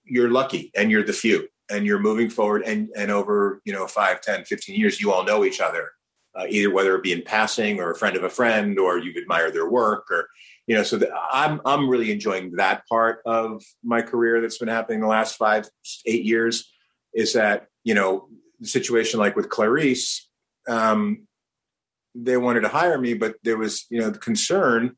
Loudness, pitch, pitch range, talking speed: -22 LUFS, 115 Hz, 110-125 Hz, 205 wpm